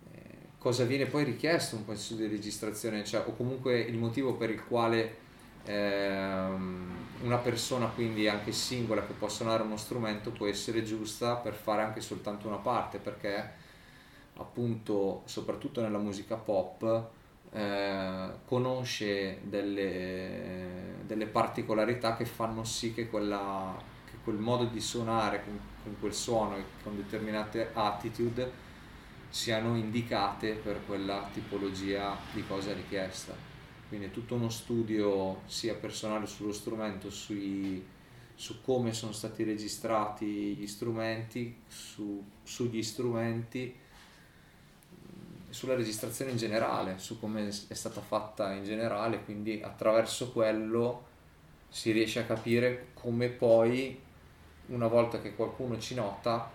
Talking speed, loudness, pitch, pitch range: 125 wpm, -34 LUFS, 110 Hz, 100-115 Hz